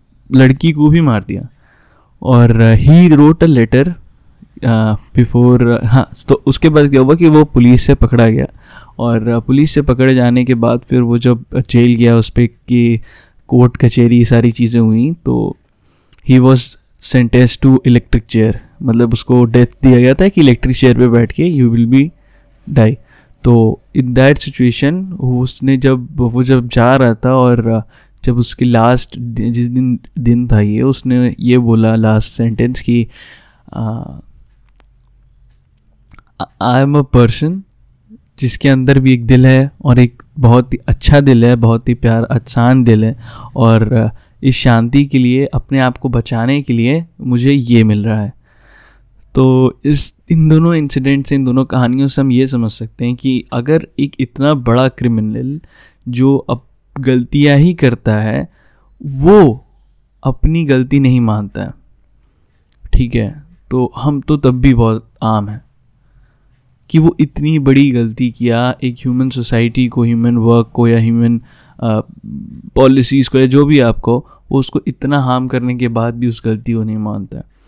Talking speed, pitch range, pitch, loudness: 165 wpm, 115-135 Hz, 125 Hz, -11 LUFS